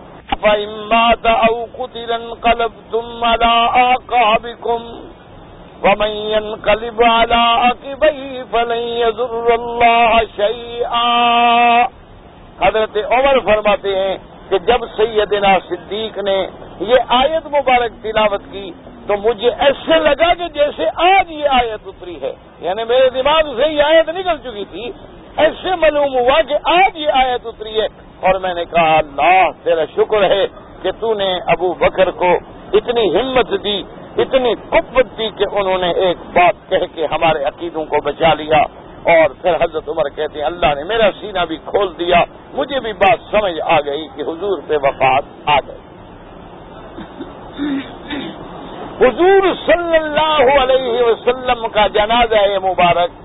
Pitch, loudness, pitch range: 230 Hz, -15 LUFS, 205-265 Hz